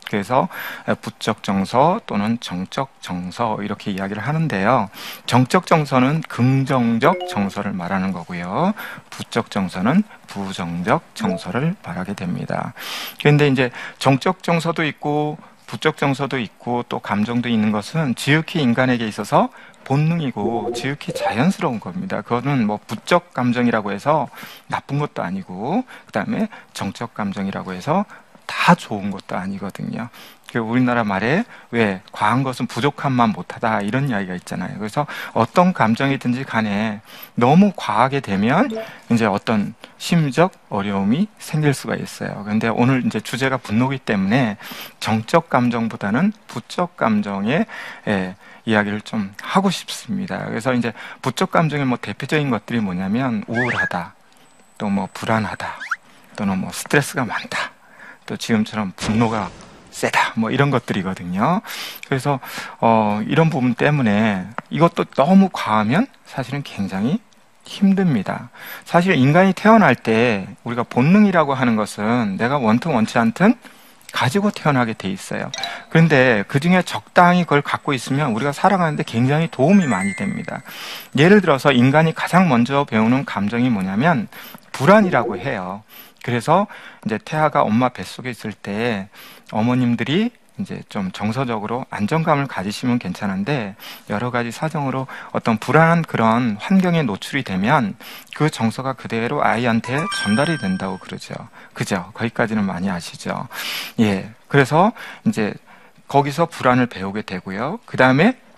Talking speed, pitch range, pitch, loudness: 315 characters per minute, 110-175 Hz, 130 Hz, -19 LUFS